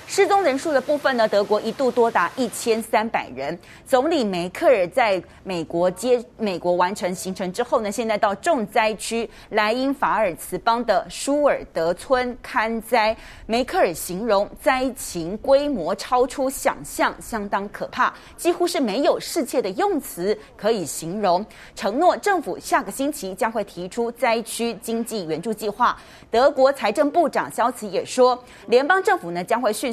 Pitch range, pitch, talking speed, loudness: 200-270 Hz, 230 Hz, 250 characters per minute, -22 LUFS